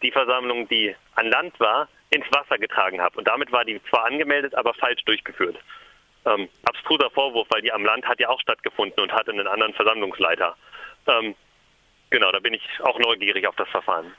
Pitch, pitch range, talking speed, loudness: 125 Hz, 115-135 Hz, 190 wpm, -22 LUFS